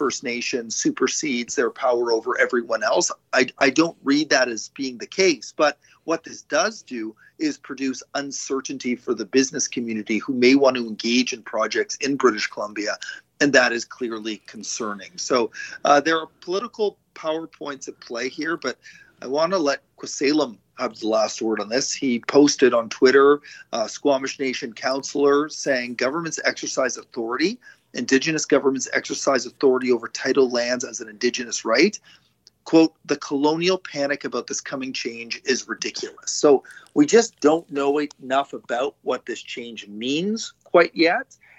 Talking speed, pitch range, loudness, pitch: 160 wpm, 120-160 Hz, -22 LUFS, 140 Hz